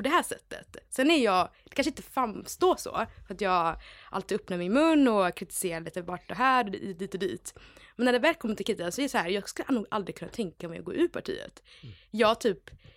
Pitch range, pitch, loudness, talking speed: 190-270 Hz, 215 Hz, -29 LUFS, 250 wpm